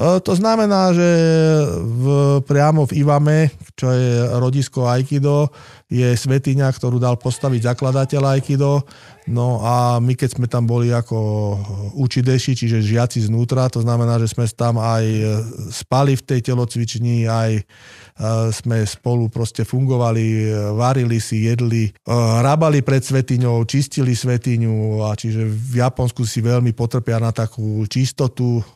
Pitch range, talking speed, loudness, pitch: 115-135 Hz, 130 wpm, -18 LUFS, 120 Hz